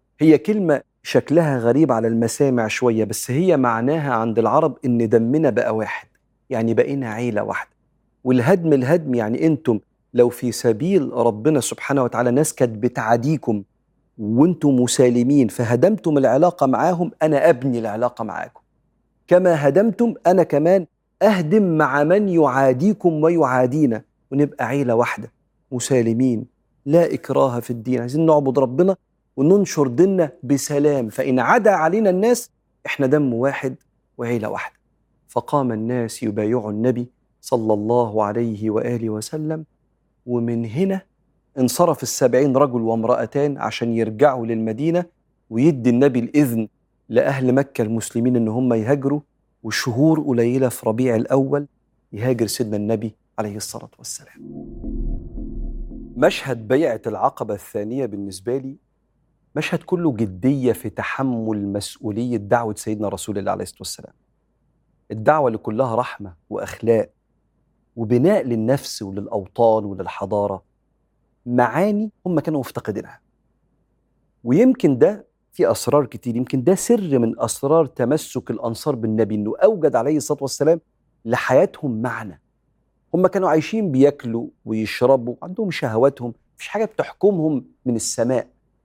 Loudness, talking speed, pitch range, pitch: -19 LUFS, 120 wpm, 115-155 Hz, 130 Hz